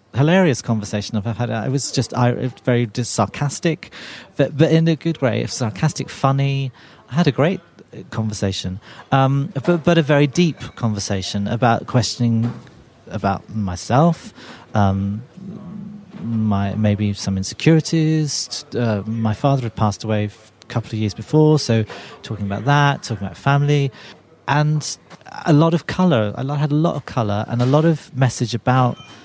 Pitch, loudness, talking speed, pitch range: 125 Hz, -19 LUFS, 155 wpm, 110-150 Hz